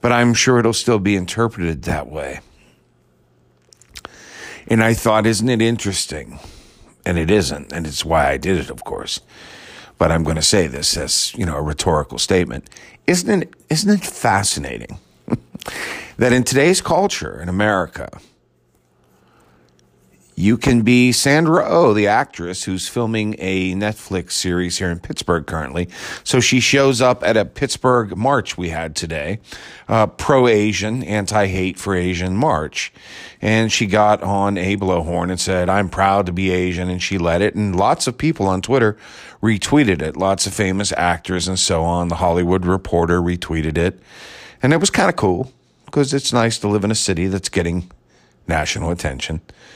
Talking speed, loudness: 170 wpm, -18 LUFS